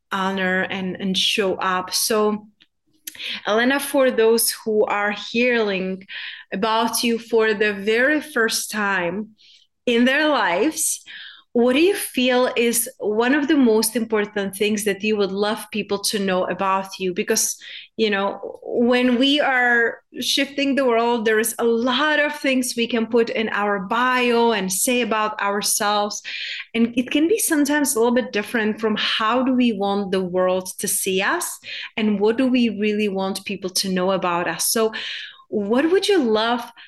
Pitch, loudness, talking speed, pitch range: 220 Hz, -20 LUFS, 165 wpm, 200-250 Hz